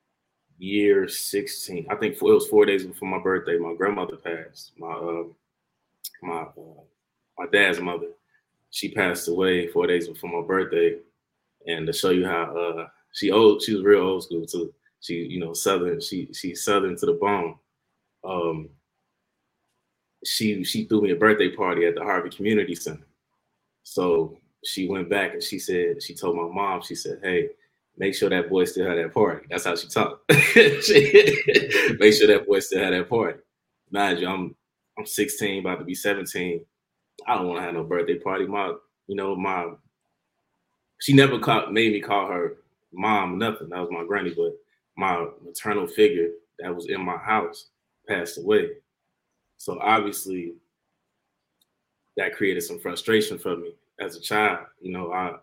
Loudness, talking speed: -23 LUFS, 175 wpm